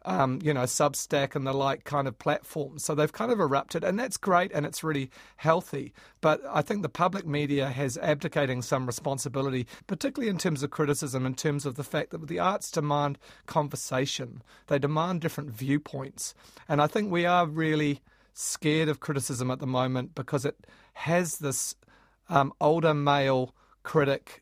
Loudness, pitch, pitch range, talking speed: -28 LUFS, 145 Hz, 135-160 Hz, 175 wpm